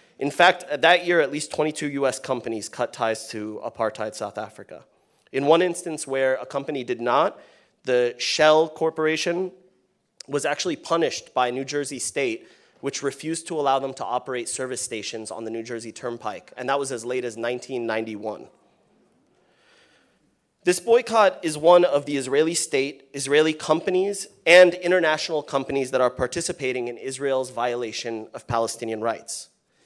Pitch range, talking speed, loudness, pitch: 120-160 Hz, 155 wpm, -23 LUFS, 135 Hz